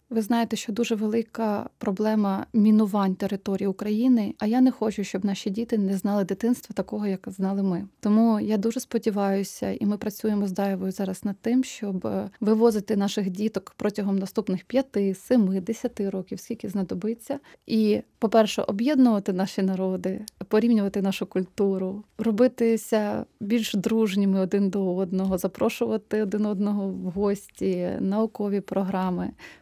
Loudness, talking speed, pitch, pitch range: -25 LUFS, 140 wpm, 210 Hz, 195-225 Hz